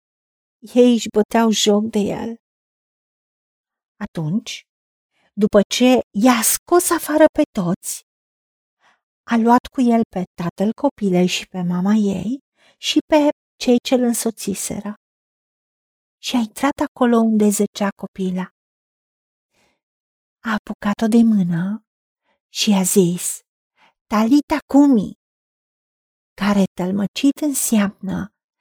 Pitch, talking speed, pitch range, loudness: 220 Hz, 105 wpm, 200-250 Hz, -18 LUFS